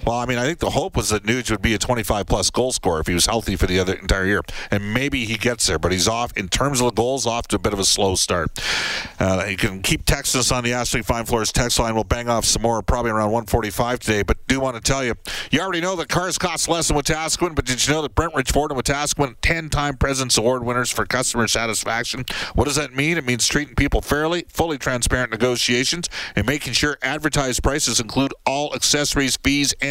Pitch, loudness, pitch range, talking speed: 125 Hz, -20 LUFS, 110-140 Hz, 240 wpm